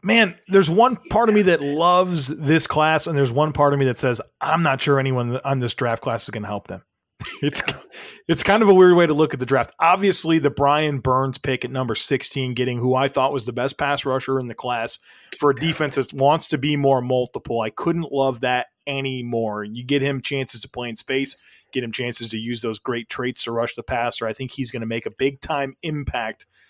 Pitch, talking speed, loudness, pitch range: 135 Hz, 240 wpm, -21 LUFS, 125-155 Hz